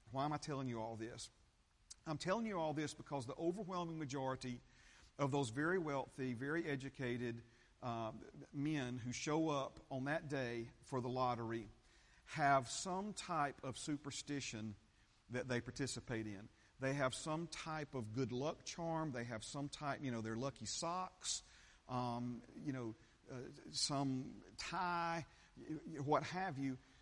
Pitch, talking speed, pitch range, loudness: 135 Hz, 150 wpm, 120-150 Hz, -44 LUFS